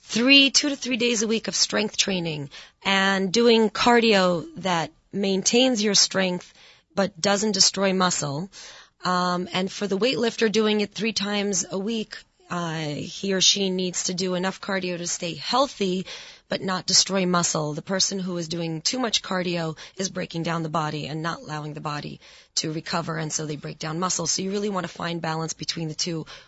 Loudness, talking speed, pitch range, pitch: -23 LUFS, 190 wpm, 165-200 Hz, 185 Hz